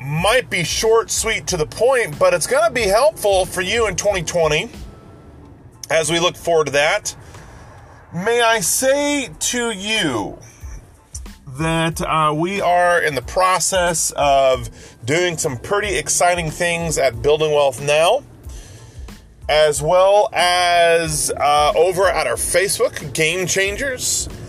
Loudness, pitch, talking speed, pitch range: -17 LUFS, 170 Hz, 135 wpm, 150-200 Hz